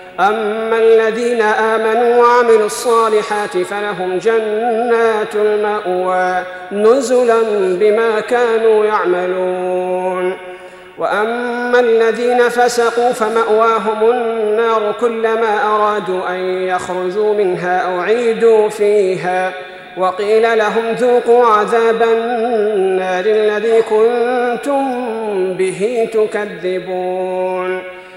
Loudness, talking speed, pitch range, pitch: -14 LUFS, 70 wpm, 185-230 Hz, 215 Hz